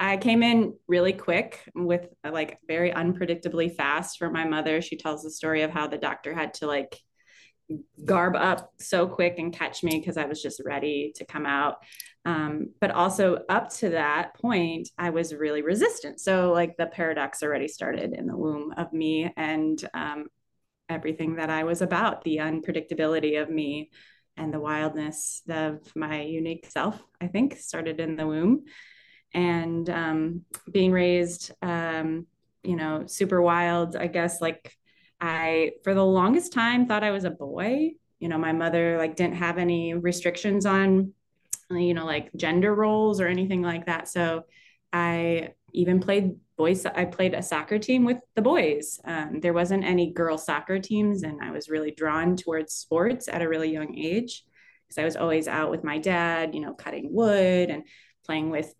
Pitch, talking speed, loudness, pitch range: 170 Hz, 180 wpm, -26 LUFS, 160-180 Hz